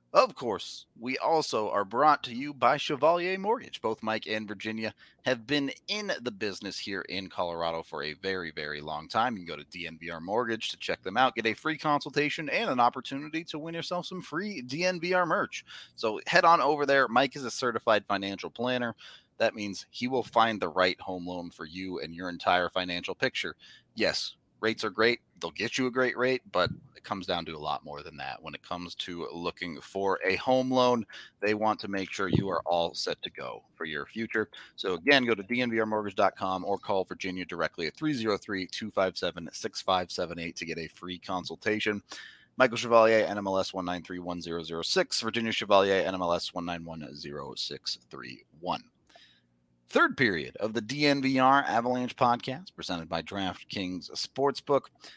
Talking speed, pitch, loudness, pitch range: 175 wpm, 110 Hz, -29 LUFS, 90-130 Hz